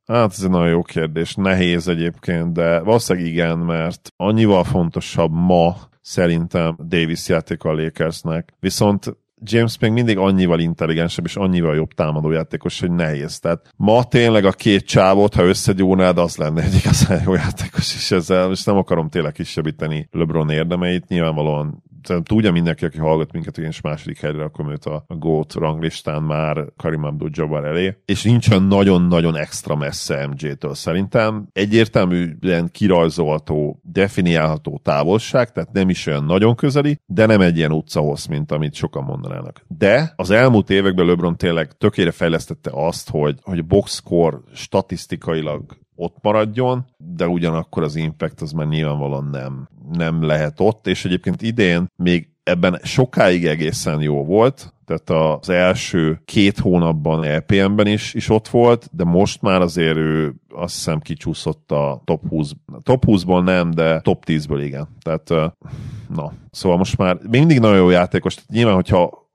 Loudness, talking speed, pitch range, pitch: -18 LUFS, 155 wpm, 80-100 Hz, 85 Hz